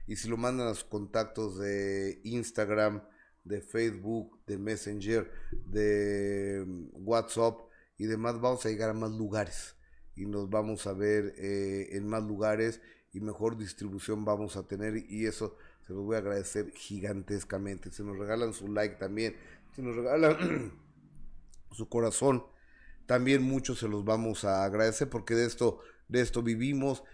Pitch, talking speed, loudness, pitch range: 110 Hz, 155 wpm, -33 LUFS, 100-115 Hz